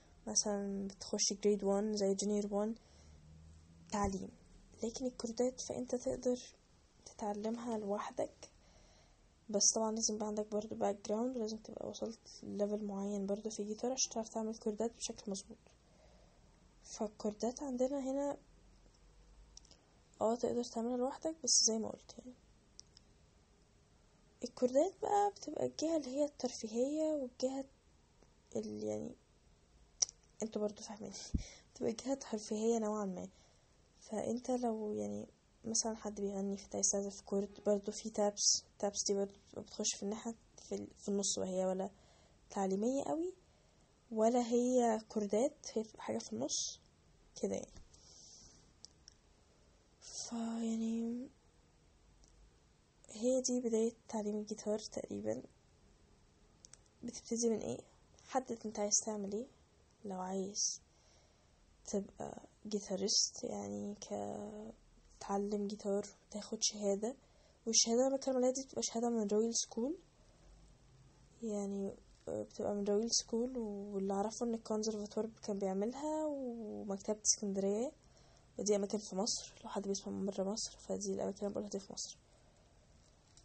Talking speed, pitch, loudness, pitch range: 120 wpm, 215 Hz, -38 LUFS, 200-235 Hz